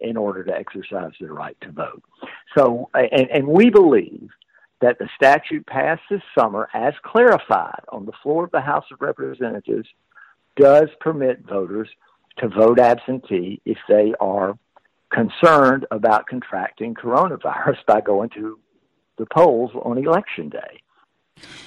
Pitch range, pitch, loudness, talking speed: 110-160 Hz, 125 Hz, -18 LUFS, 140 wpm